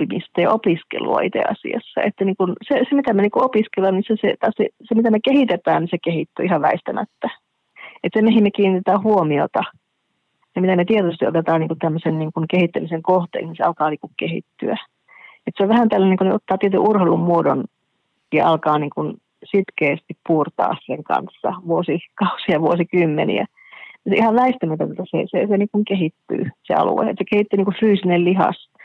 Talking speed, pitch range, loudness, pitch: 180 wpm, 170-215 Hz, -19 LUFS, 190 Hz